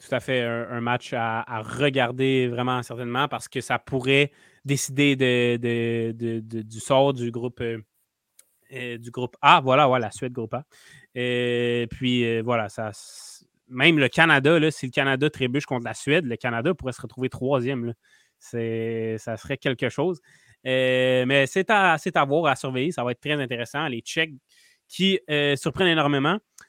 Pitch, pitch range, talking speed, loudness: 130 Hz, 120-140 Hz, 185 wpm, -23 LUFS